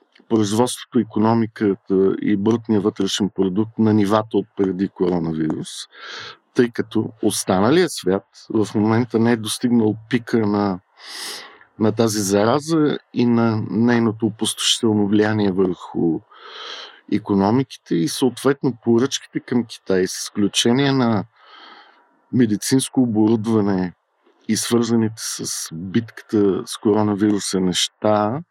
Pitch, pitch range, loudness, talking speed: 110 Hz, 100-120 Hz, -19 LUFS, 105 wpm